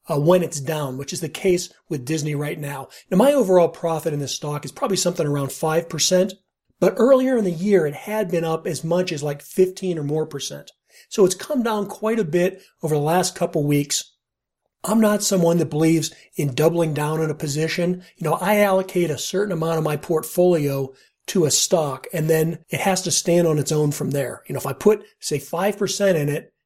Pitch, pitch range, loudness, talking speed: 165 Hz, 150-185 Hz, -21 LUFS, 220 wpm